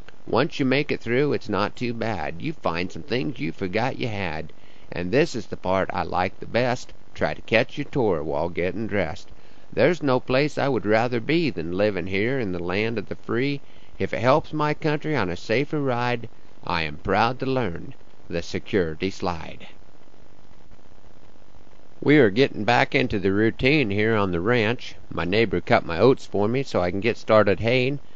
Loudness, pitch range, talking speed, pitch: -24 LUFS, 95-130 Hz, 195 wpm, 110 Hz